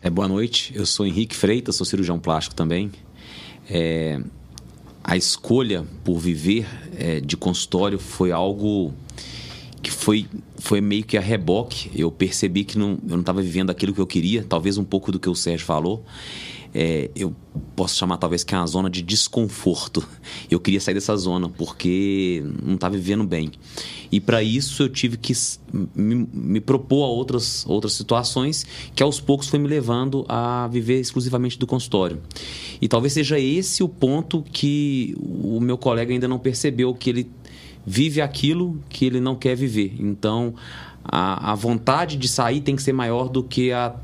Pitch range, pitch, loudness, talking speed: 90-125 Hz, 105 Hz, -22 LUFS, 175 wpm